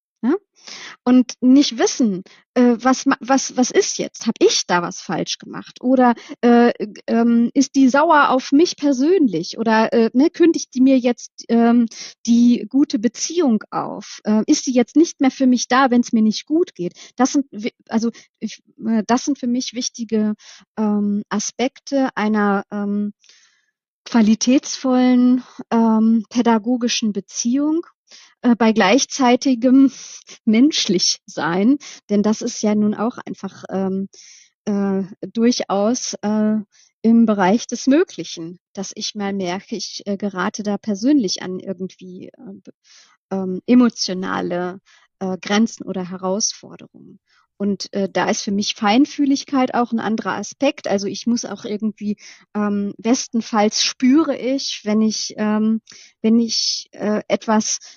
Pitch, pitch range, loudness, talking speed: 230 Hz, 205-260 Hz, -18 LUFS, 140 wpm